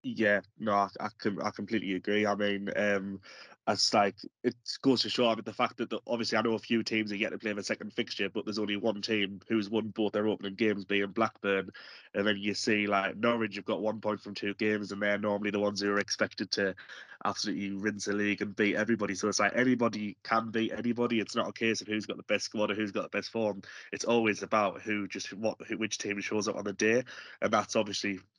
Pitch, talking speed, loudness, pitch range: 105 Hz, 245 wpm, -31 LUFS, 100-110 Hz